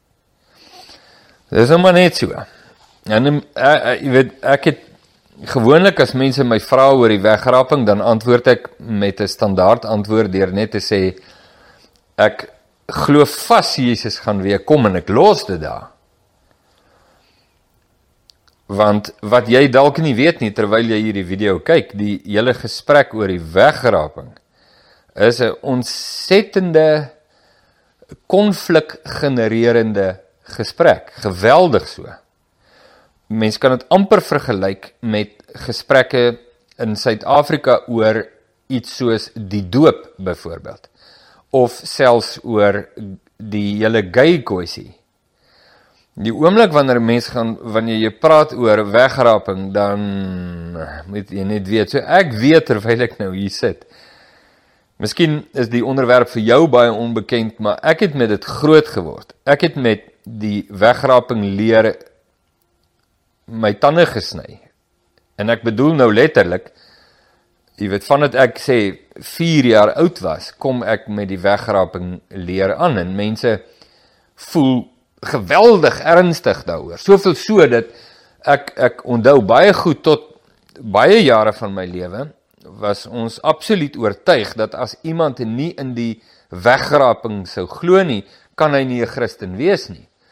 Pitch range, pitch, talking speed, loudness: 105-140 Hz, 115 Hz, 130 wpm, -14 LUFS